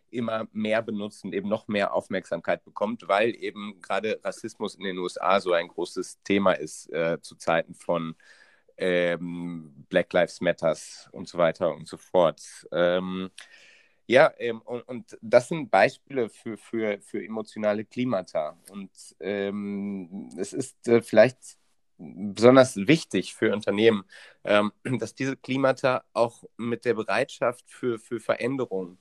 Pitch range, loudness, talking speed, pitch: 95-120 Hz, -26 LUFS, 140 wpm, 105 Hz